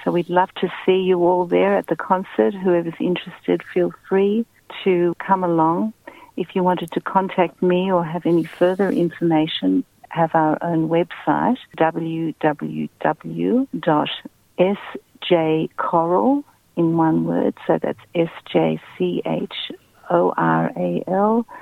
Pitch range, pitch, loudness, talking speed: 160-185 Hz, 175 Hz, -20 LUFS, 130 wpm